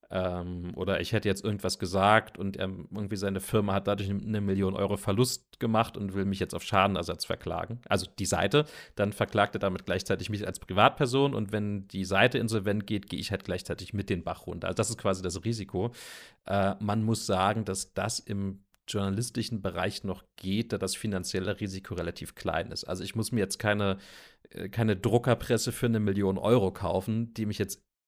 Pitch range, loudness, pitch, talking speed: 95-110 Hz, -30 LUFS, 100 Hz, 190 wpm